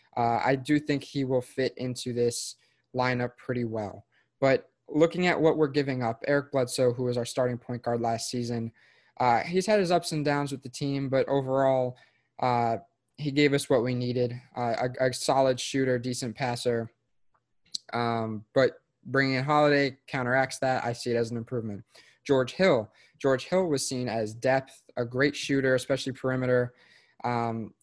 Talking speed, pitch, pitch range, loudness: 175 wpm, 130 Hz, 120-140 Hz, -28 LUFS